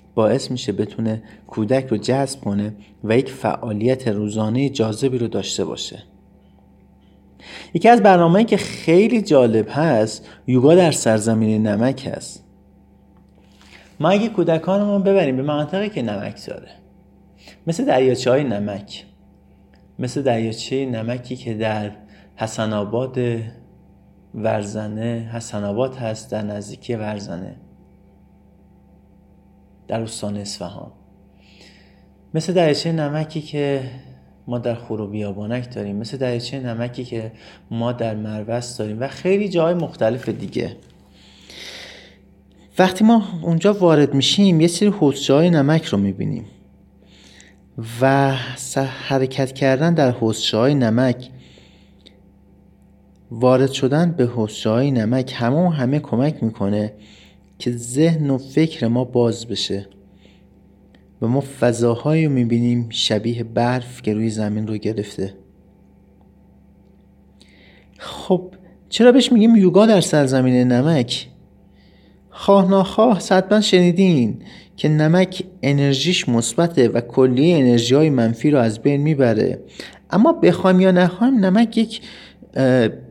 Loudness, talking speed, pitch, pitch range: -18 LUFS, 115 wpm, 120 Hz, 105-150 Hz